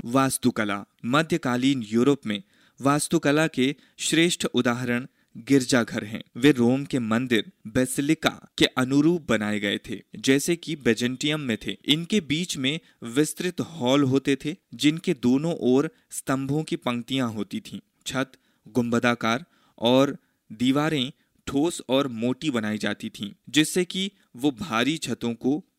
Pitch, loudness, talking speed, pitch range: 135 Hz, -25 LUFS, 130 wpm, 120-160 Hz